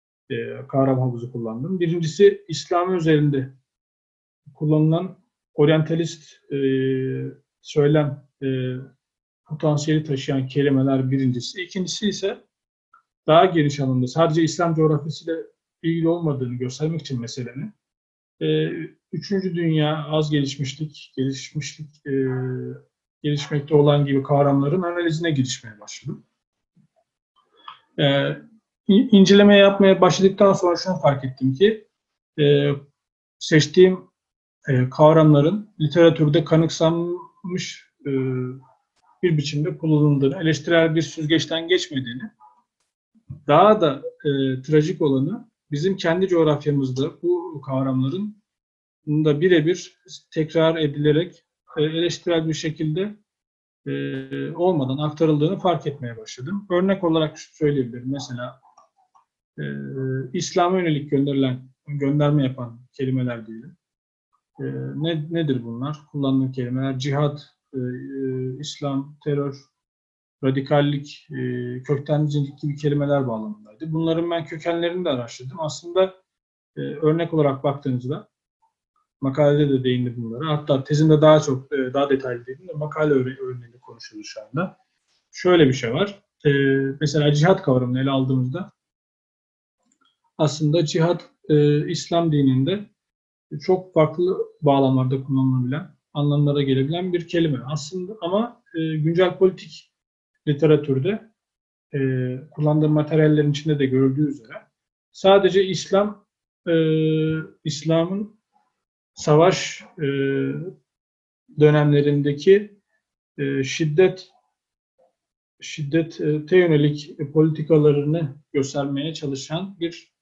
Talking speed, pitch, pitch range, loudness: 95 wpm, 150 Hz, 135-170 Hz, -21 LUFS